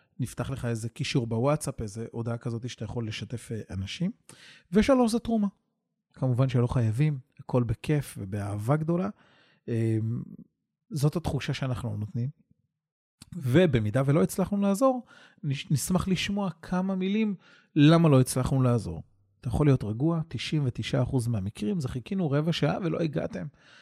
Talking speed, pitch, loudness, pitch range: 125 wpm, 140 Hz, -28 LUFS, 120-175 Hz